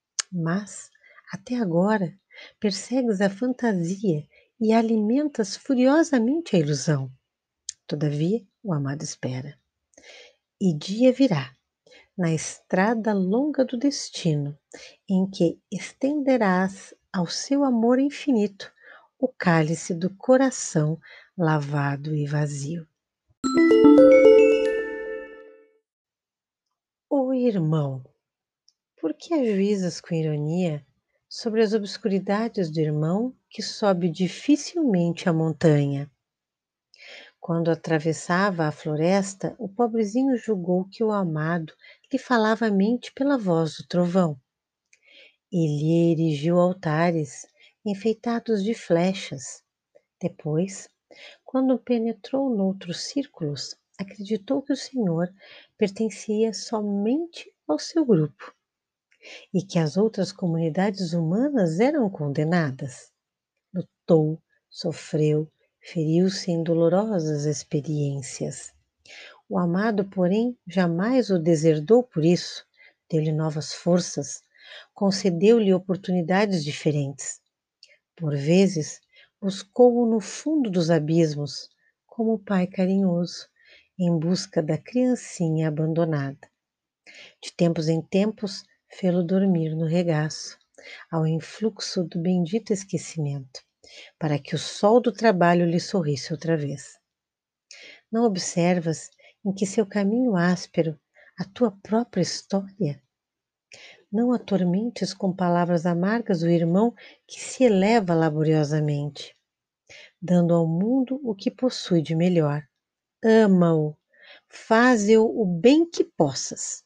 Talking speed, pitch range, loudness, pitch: 100 wpm, 160-225 Hz, -23 LUFS, 185 Hz